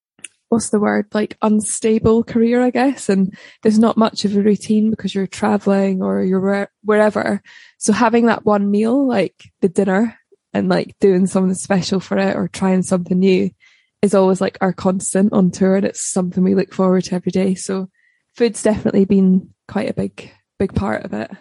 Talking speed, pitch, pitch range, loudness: 190 wpm, 200 Hz, 190-220 Hz, -17 LUFS